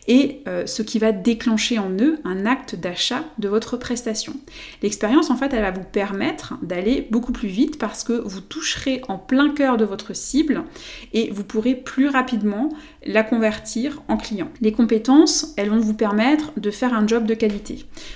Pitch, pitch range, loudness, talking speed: 235 Hz, 215-275 Hz, -21 LUFS, 180 wpm